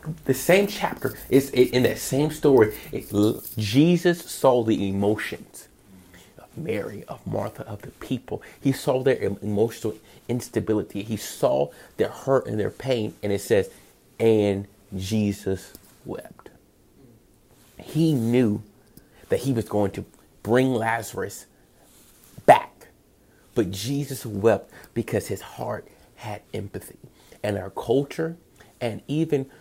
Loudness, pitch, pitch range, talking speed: -24 LUFS, 115 Hz, 105-135 Hz, 125 wpm